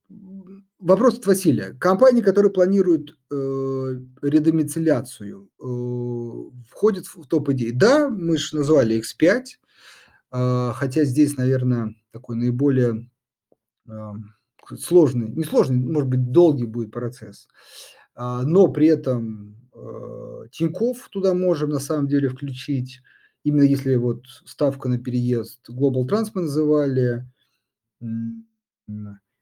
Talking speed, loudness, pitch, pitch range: 100 wpm, -21 LUFS, 135 Hz, 120-160 Hz